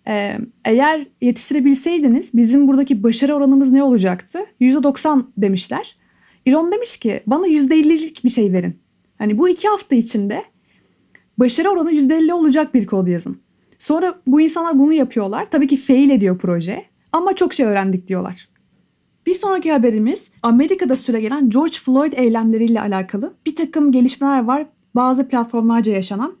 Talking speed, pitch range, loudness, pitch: 140 wpm, 230-310 Hz, -16 LUFS, 265 Hz